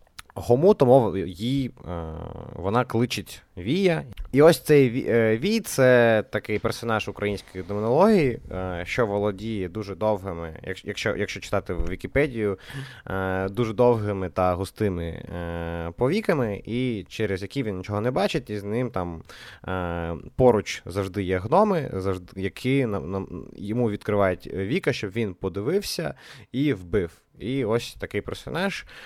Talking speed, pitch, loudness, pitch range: 135 wpm, 105 Hz, -25 LUFS, 95-125 Hz